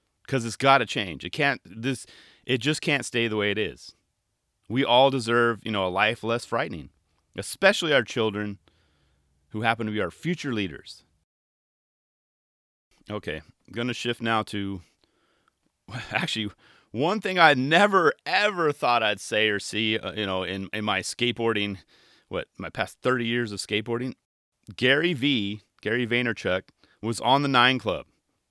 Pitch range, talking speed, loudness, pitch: 100-125 Hz, 155 wpm, -25 LUFS, 110 Hz